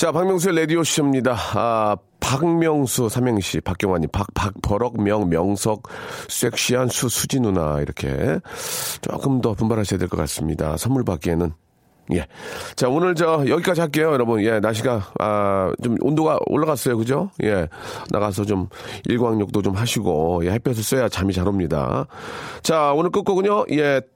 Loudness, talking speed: -21 LUFS, 310 characters per minute